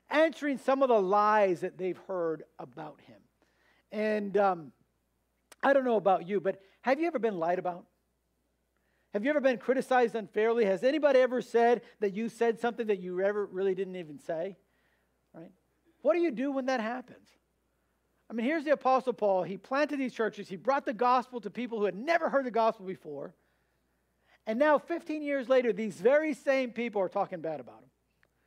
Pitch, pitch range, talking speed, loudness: 220 Hz, 190-260 Hz, 190 wpm, -29 LUFS